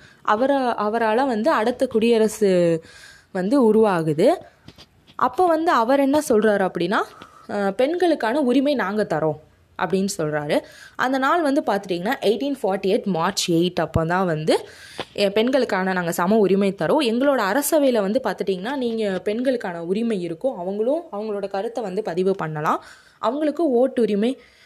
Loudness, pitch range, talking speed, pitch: -21 LUFS, 190-265 Hz, 125 wpm, 215 Hz